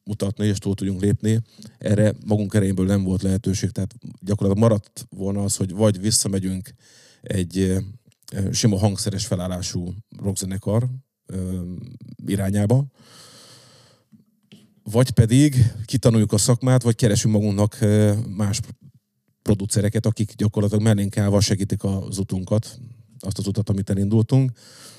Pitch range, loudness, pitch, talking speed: 100-115 Hz, -21 LUFS, 105 Hz, 115 wpm